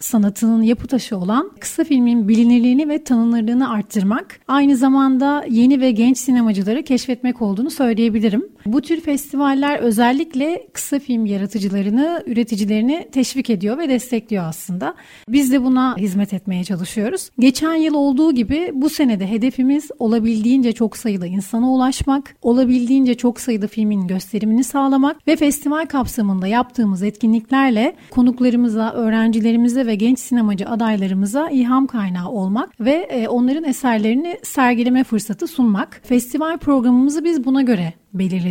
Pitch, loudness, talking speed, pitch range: 245 Hz, -17 LUFS, 130 wpm, 220-275 Hz